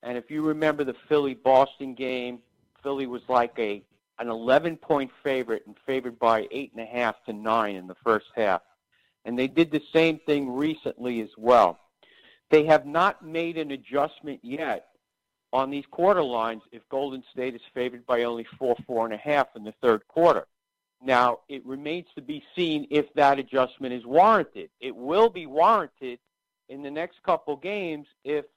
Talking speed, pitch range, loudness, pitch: 180 wpm, 120-155 Hz, -25 LUFS, 135 Hz